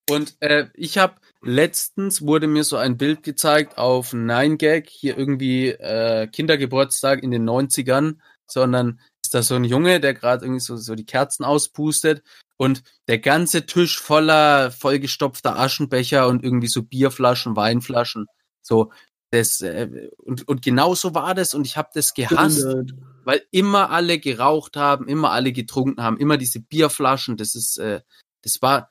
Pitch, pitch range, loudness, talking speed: 135 Hz, 125-150 Hz, -19 LUFS, 160 wpm